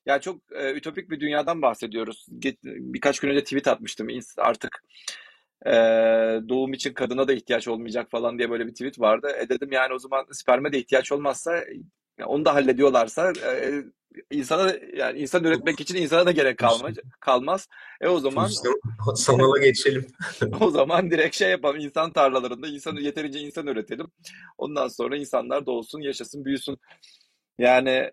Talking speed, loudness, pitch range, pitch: 160 wpm, -24 LUFS, 125-145 Hz, 135 Hz